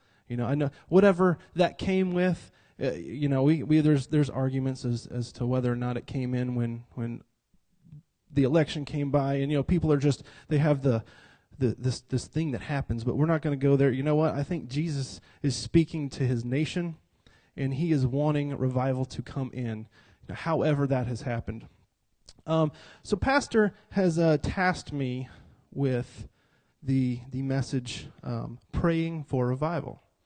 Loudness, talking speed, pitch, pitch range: -28 LUFS, 185 wpm, 140 Hz, 125-155 Hz